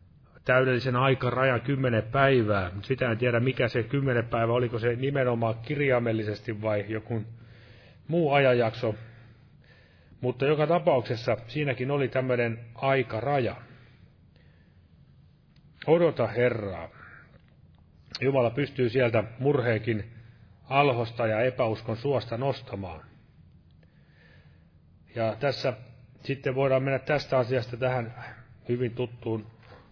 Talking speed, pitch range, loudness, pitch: 95 wpm, 110-130 Hz, -27 LUFS, 120 Hz